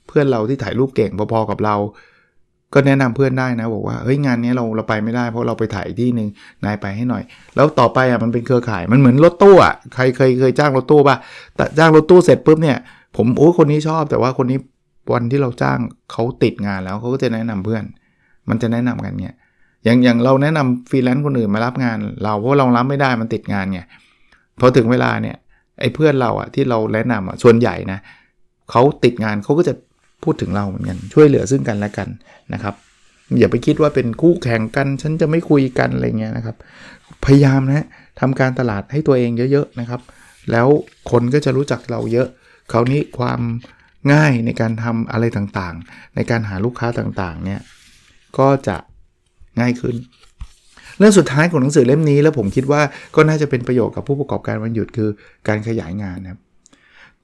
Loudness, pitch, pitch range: -16 LUFS, 120 Hz, 110-135 Hz